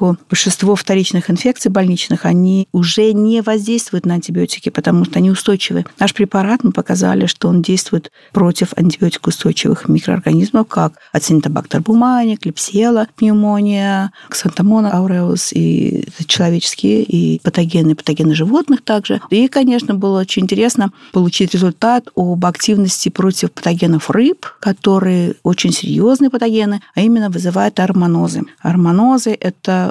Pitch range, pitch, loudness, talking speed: 175-215 Hz, 190 Hz, -14 LUFS, 120 wpm